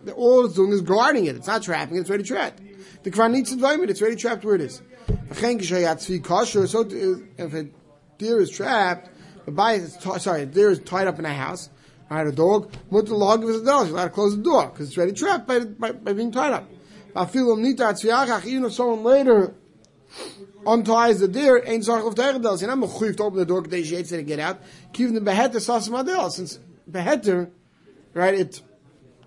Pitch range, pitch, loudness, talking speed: 180-235 Hz, 205 Hz, -22 LUFS, 200 wpm